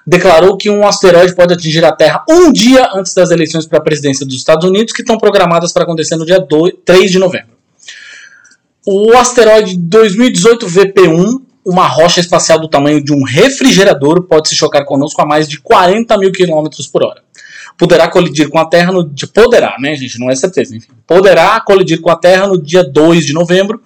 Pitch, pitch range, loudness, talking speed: 180 Hz, 155-200 Hz, -8 LUFS, 190 wpm